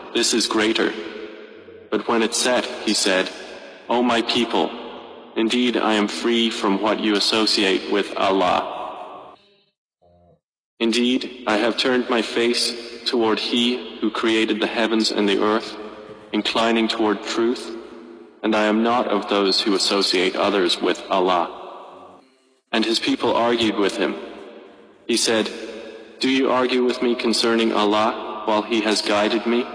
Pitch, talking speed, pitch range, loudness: 110 Hz, 145 wpm, 105-120 Hz, -20 LUFS